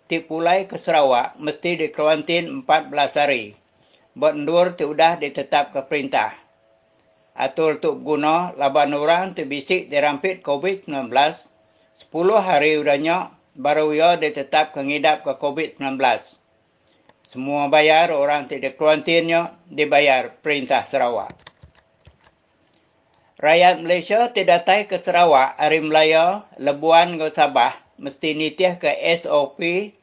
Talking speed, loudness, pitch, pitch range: 120 wpm, -19 LUFS, 155 Hz, 145-170 Hz